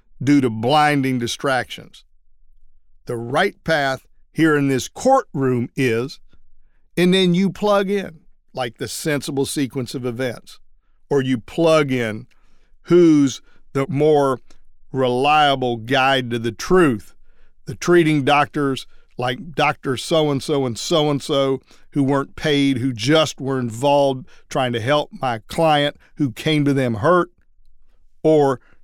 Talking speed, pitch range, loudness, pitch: 135 wpm, 125-150 Hz, -19 LUFS, 140 Hz